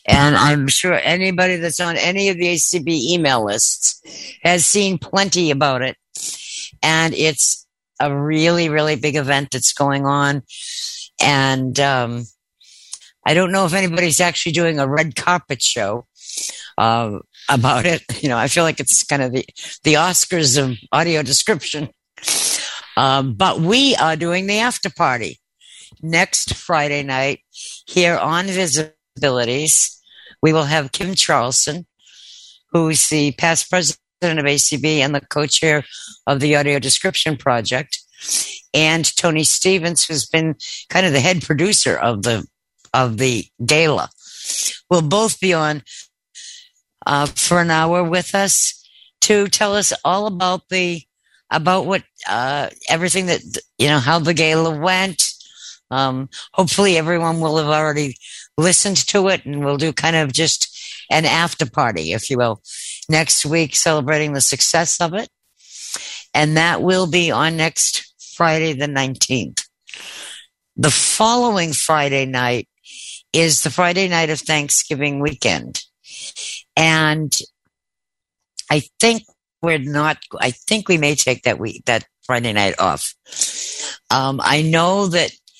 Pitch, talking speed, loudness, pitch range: 155 Hz, 140 wpm, -16 LUFS, 140-175 Hz